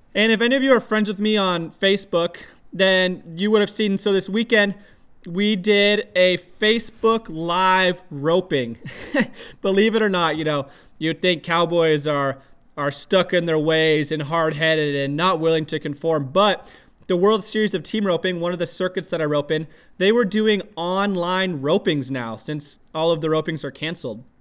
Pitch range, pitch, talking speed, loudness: 155-205 Hz, 180 Hz, 185 wpm, -20 LUFS